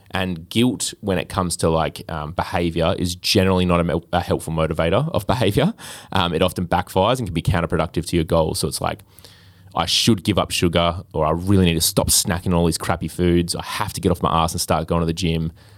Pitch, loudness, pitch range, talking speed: 90 Hz, -20 LUFS, 85-95 Hz, 235 wpm